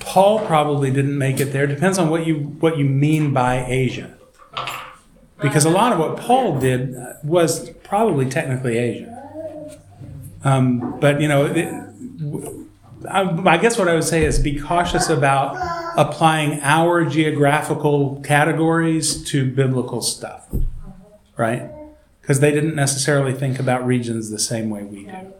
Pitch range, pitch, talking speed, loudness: 135-165 Hz, 150 Hz, 145 wpm, -19 LUFS